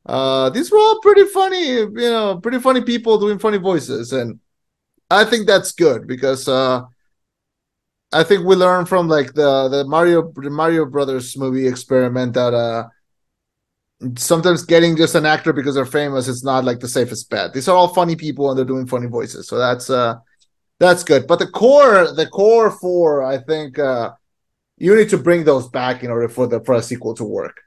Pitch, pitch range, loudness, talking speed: 150 Hz, 130-185 Hz, -16 LUFS, 195 wpm